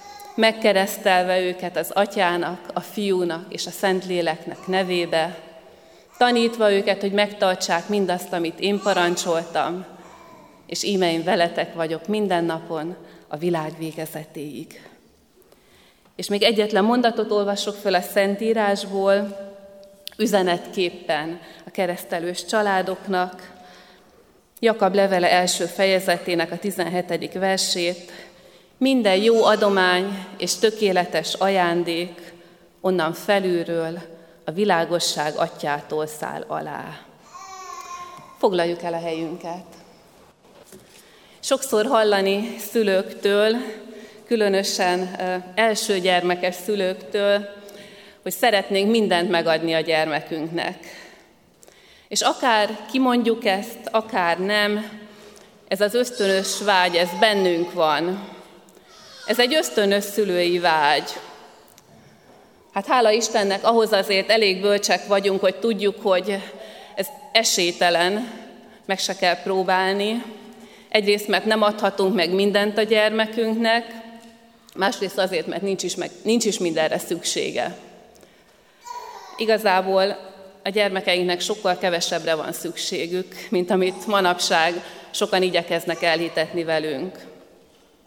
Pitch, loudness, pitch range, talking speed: 190 Hz, -21 LUFS, 175-210 Hz, 100 wpm